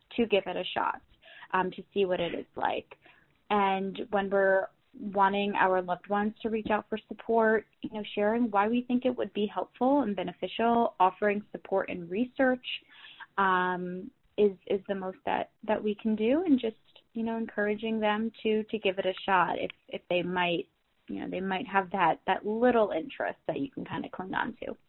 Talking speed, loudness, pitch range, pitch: 200 wpm, -30 LUFS, 190-225 Hz, 210 Hz